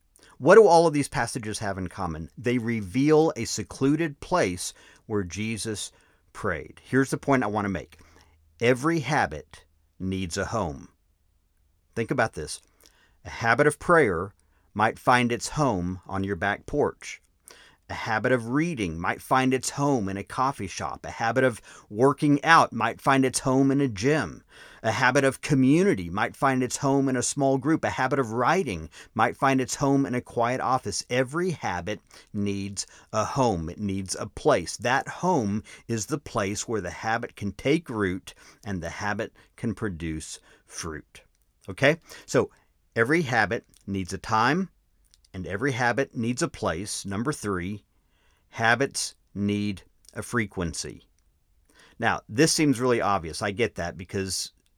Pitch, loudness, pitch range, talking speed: 110 Hz, -25 LUFS, 95-135 Hz, 160 wpm